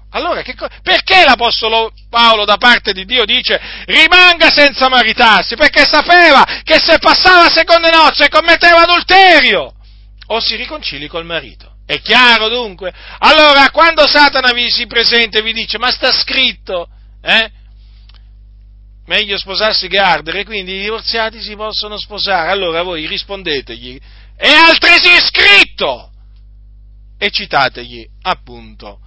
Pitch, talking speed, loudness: 225 Hz, 135 wpm, -8 LUFS